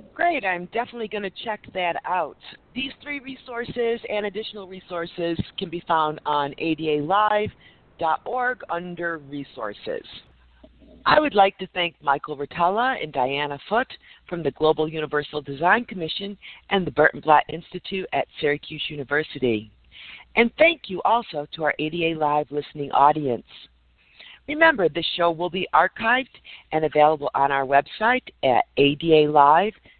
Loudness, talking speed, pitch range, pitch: -23 LUFS, 135 wpm, 150-215 Hz, 170 Hz